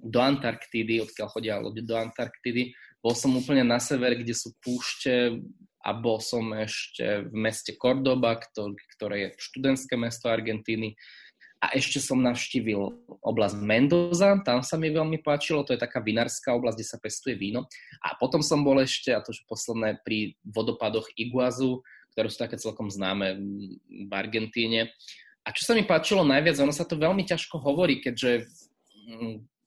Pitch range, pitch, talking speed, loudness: 110-135 Hz, 120 Hz, 160 wpm, -27 LUFS